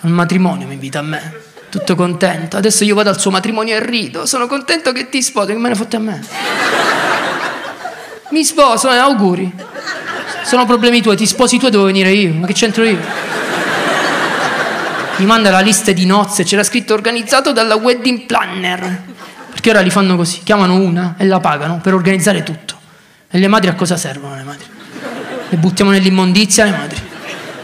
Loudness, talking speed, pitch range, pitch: -12 LUFS, 180 wpm, 185-230 Hz, 200 Hz